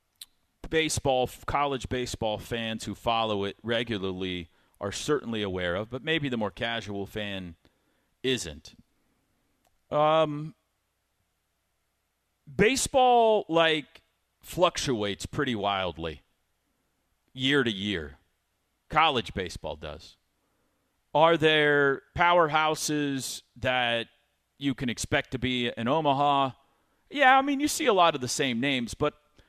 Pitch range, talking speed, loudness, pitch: 100-150 Hz, 110 wpm, -27 LUFS, 120 Hz